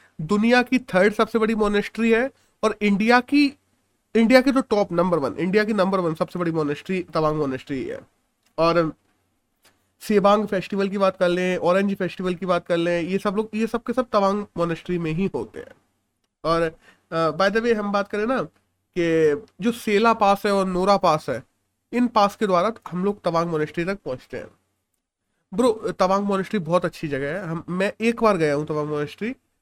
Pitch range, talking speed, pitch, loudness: 170-220 Hz, 190 wpm, 195 Hz, -22 LUFS